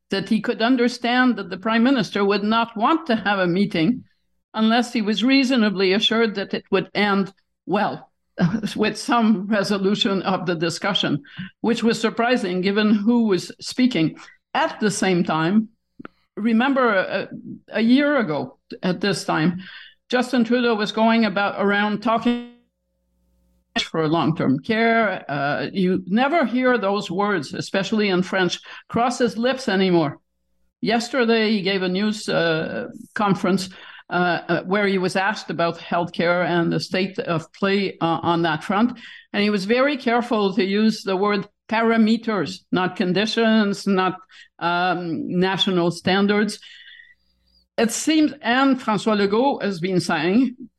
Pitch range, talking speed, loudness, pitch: 185-230 Hz, 145 wpm, -21 LUFS, 205 Hz